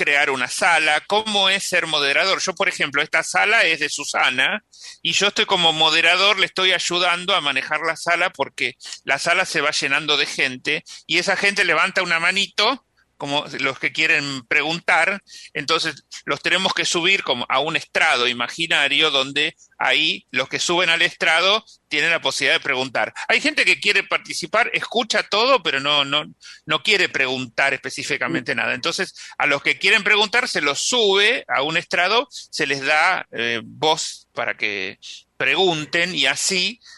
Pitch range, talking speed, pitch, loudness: 140-190 Hz, 170 wpm, 160 Hz, -18 LUFS